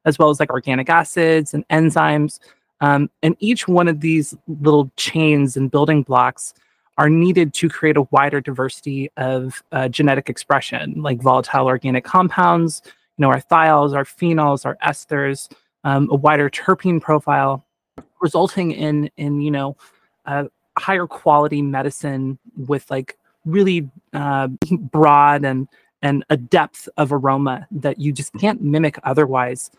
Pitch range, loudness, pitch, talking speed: 140-160 Hz, -17 LUFS, 145 Hz, 150 wpm